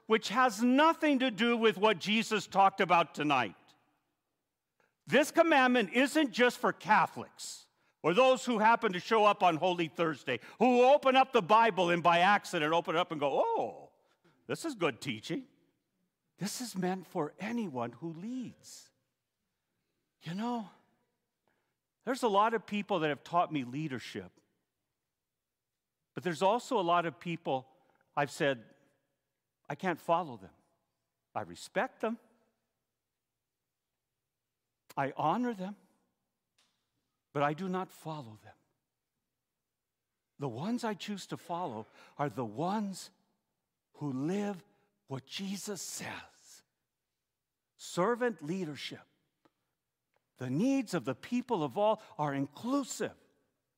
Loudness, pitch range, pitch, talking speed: -31 LUFS, 145-230 Hz, 185 Hz, 125 wpm